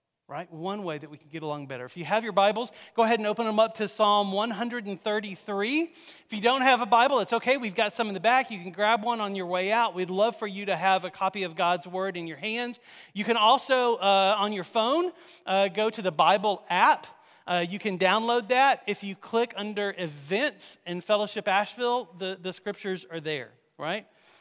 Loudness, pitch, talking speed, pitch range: -26 LUFS, 205 Hz, 225 wpm, 185-230 Hz